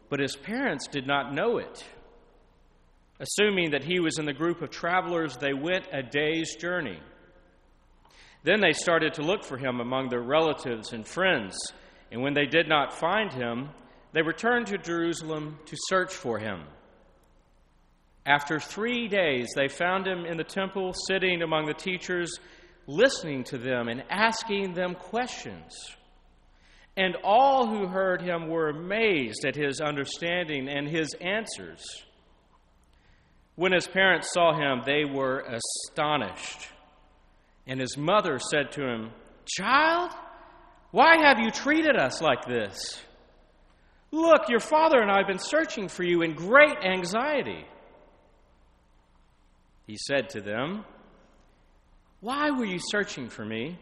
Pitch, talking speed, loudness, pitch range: 165 Hz, 140 wpm, -26 LUFS, 135-195 Hz